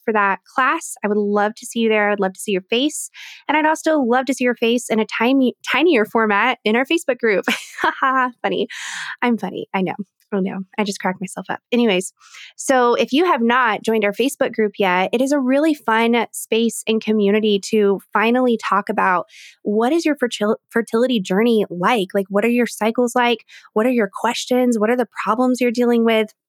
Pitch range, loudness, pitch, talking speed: 210-250 Hz, -18 LUFS, 230 Hz, 205 wpm